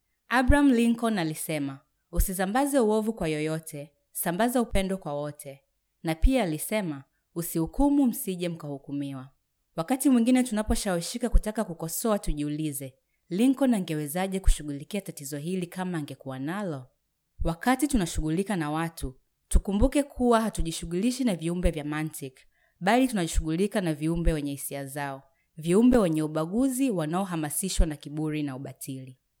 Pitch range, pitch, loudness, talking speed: 150-215 Hz, 170 Hz, -28 LUFS, 115 wpm